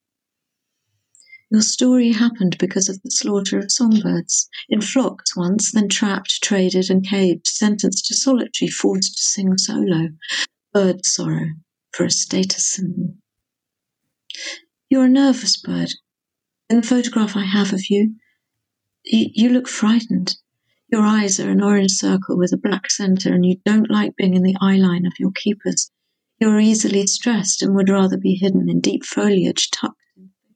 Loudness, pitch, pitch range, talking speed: -18 LUFS, 200 Hz, 185-225 Hz, 155 wpm